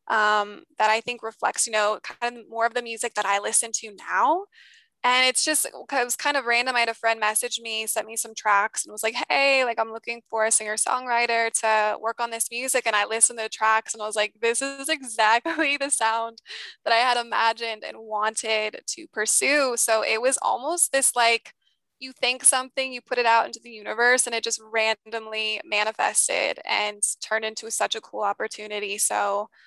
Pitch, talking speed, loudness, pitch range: 230 Hz, 210 wpm, -23 LUFS, 220-245 Hz